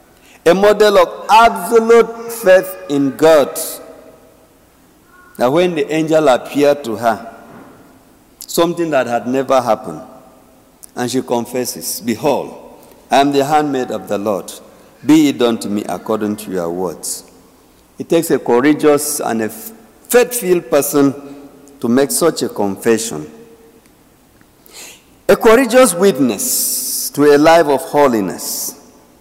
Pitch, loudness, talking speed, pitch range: 145 Hz, -14 LUFS, 125 wpm, 125-175 Hz